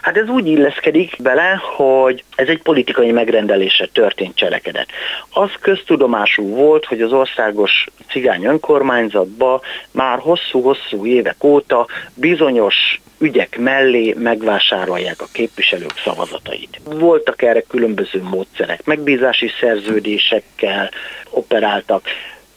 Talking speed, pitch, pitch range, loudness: 100 wpm, 130 Hz, 115-155 Hz, -15 LUFS